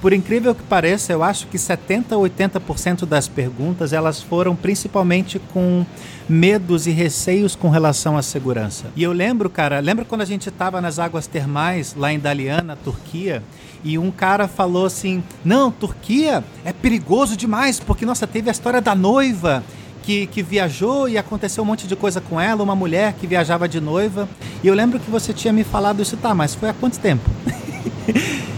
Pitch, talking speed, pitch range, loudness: 185 Hz, 185 wpm, 165-210 Hz, -19 LUFS